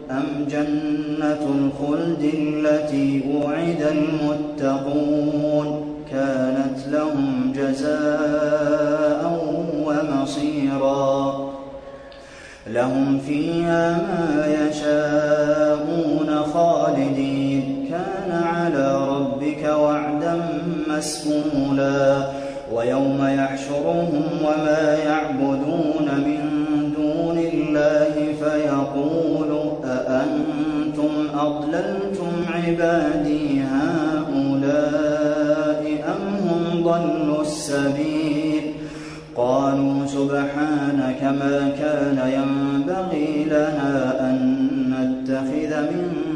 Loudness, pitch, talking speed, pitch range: -21 LUFS, 150 Hz, 55 wpm, 140-155 Hz